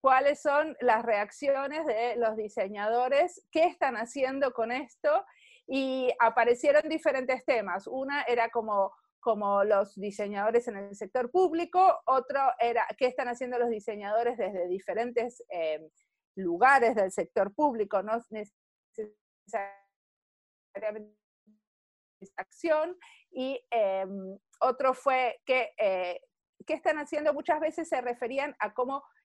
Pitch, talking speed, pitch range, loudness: 245 Hz, 125 wpm, 210-285 Hz, -29 LUFS